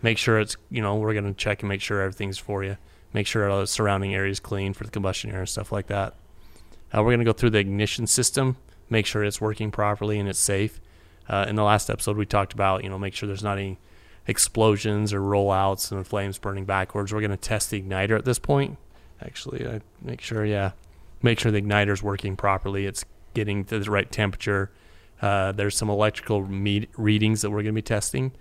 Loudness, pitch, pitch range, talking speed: -25 LUFS, 100 Hz, 95-110 Hz, 220 wpm